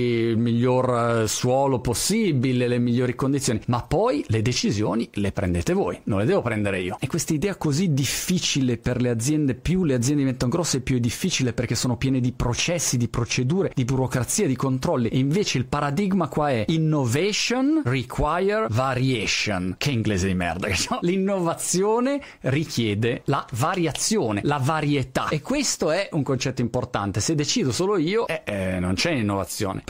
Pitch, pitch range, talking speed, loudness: 130 Hz, 120-155 Hz, 165 wpm, -23 LUFS